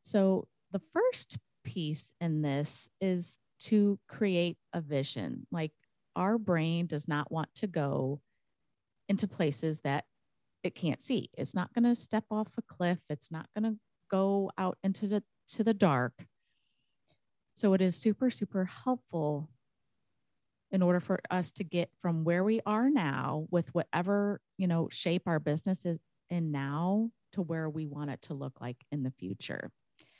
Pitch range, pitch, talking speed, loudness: 150-200 Hz, 175 Hz, 165 wpm, -33 LUFS